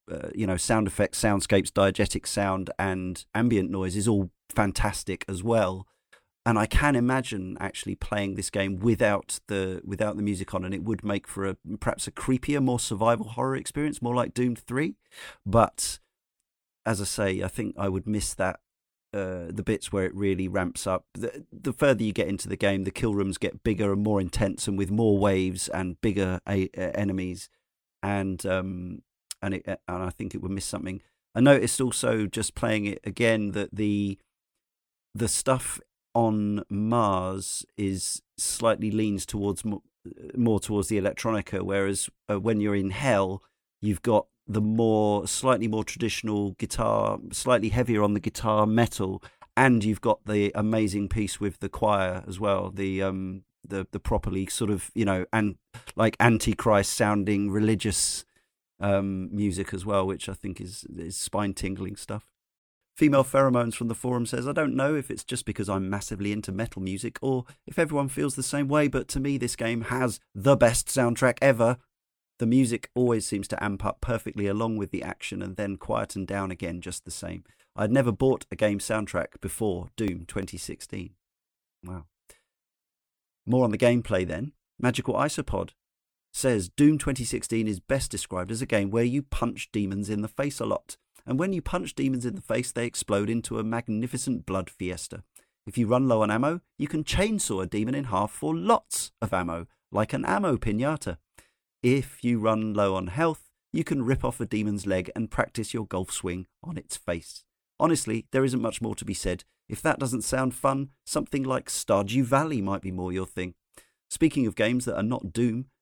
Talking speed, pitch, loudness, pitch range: 185 wpm, 105 Hz, -27 LUFS, 95-120 Hz